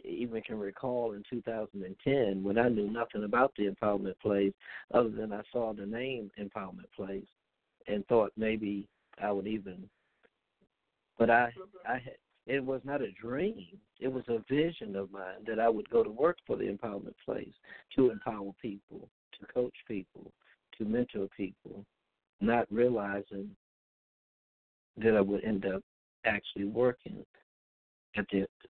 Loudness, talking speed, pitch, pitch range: -33 LUFS, 150 wpm, 110 Hz, 100-120 Hz